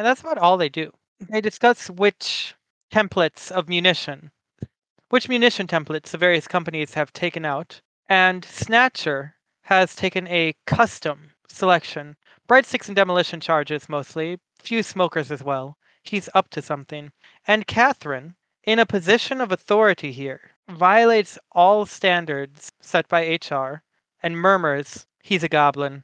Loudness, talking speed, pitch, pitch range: -20 LUFS, 140 wpm, 175 Hz, 150-200 Hz